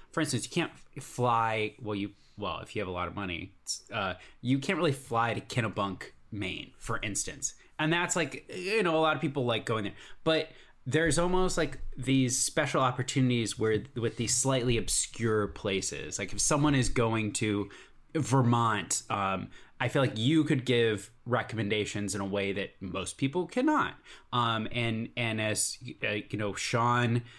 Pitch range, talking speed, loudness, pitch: 105-140 Hz, 175 wpm, -30 LUFS, 120 Hz